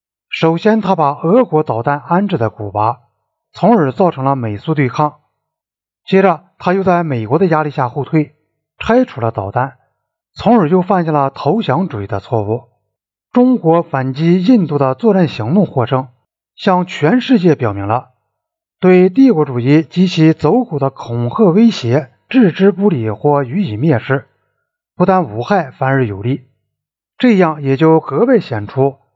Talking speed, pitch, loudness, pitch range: 230 characters per minute, 150 Hz, -13 LUFS, 125-190 Hz